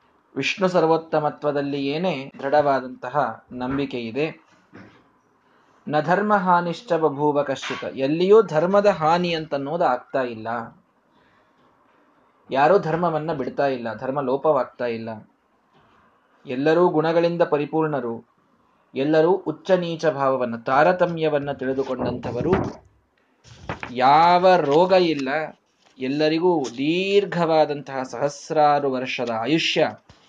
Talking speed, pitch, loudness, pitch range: 80 wpm, 150 Hz, -21 LUFS, 135-170 Hz